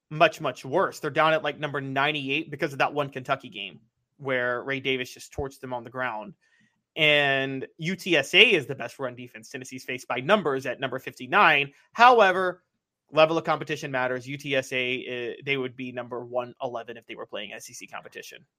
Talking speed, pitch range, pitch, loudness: 180 wpm, 125-155 Hz, 135 Hz, -24 LUFS